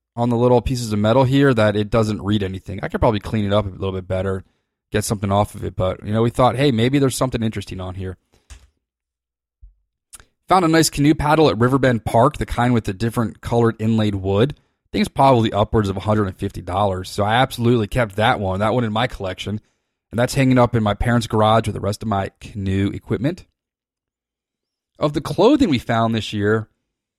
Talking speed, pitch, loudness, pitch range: 210 wpm, 110 Hz, -19 LUFS, 100-120 Hz